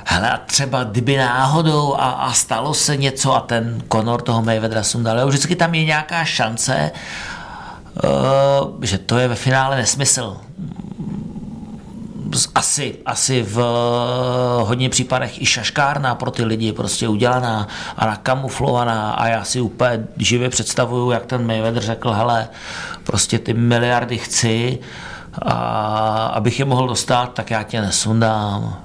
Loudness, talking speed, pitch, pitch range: -18 LUFS, 135 wpm, 120 Hz, 115-135 Hz